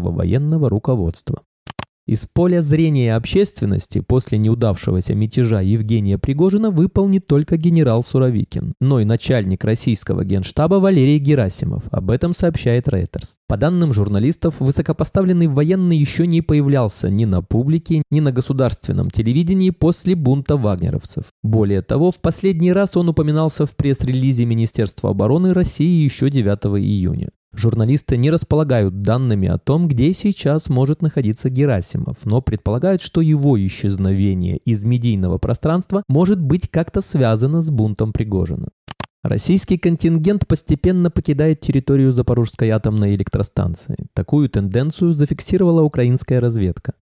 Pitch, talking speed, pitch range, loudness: 135 Hz, 125 wpm, 110-160 Hz, -17 LUFS